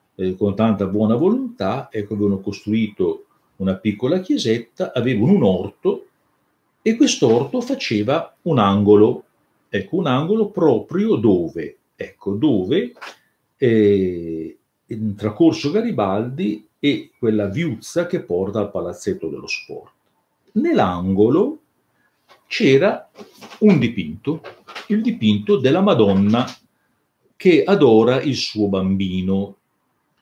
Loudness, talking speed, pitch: -19 LUFS, 105 wpm, 110 Hz